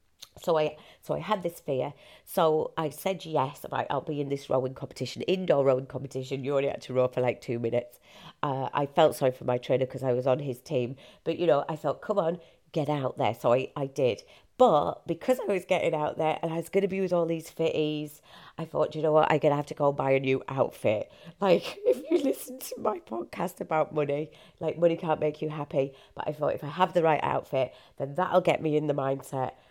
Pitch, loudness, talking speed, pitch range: 150 Hz, -28 LUFS, 240 wpm, 135-165 Hz